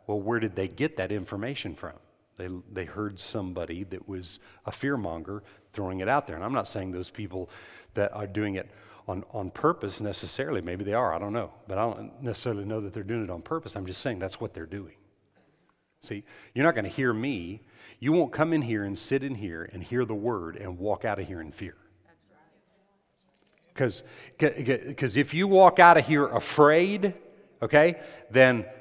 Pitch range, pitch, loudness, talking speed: 95-135 Hz, 105 Hz, -27 LUFS, 200 wpm